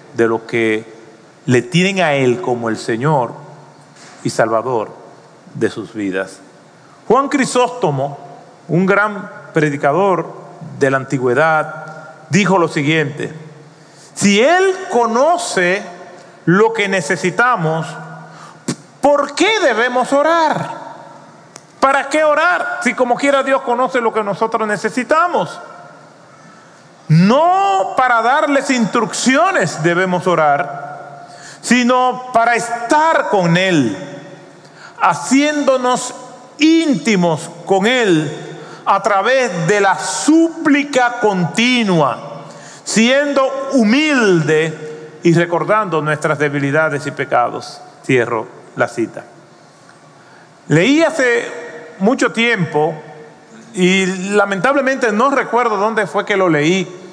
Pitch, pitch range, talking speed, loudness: 195 Hz, 155-250 Hz, 100 wpm, -14 LUFS